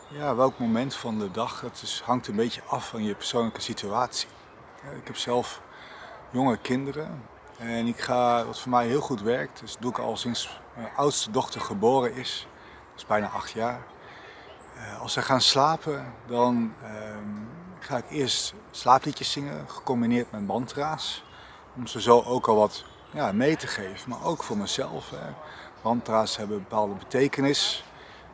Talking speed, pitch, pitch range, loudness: 170 wpm, 120 Hz, 110-130 Hz, -27 LUFS